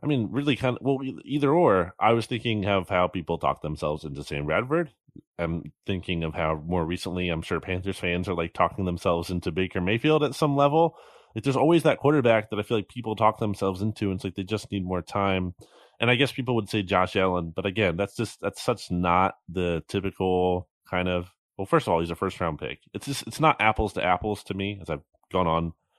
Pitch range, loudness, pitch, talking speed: 90-115 Hz, -26 LUFS, 95 Hz, 235 wpm